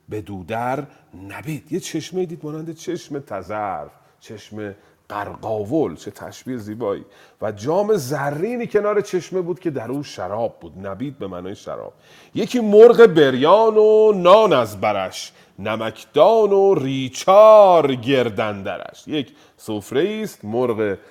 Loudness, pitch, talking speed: -17 LUFS, 140 Hz, 125 wpm